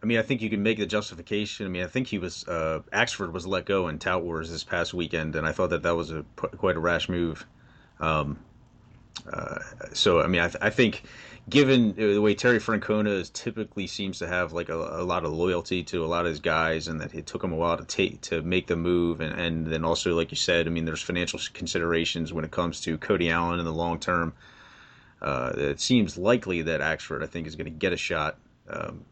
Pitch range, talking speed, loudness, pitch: 80-100 Hz, 245 wpm, -27 LUFS, 85 Hz